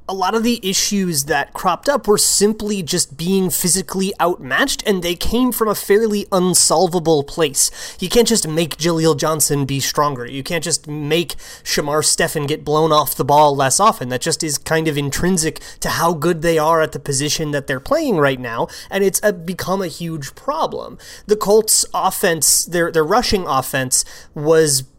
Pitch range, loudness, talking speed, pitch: 150-190 Hz, -17 LUFS, 185 wpm, 165 Hz